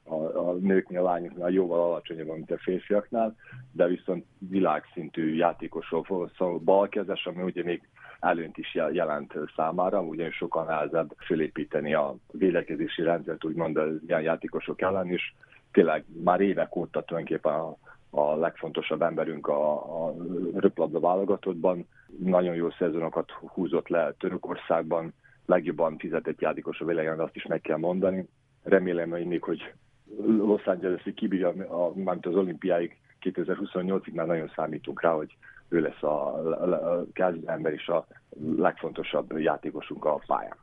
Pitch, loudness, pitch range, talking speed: 90 Hz, -28 LUFS, 85-95 Hz, 135 wpm